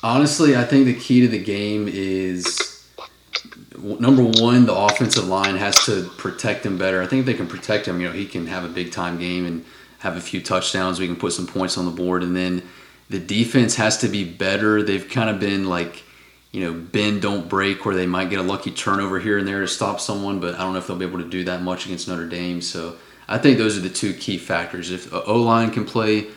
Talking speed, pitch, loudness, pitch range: 250 wpm, 95 Hz, -20 LUFS, 90-105 Hz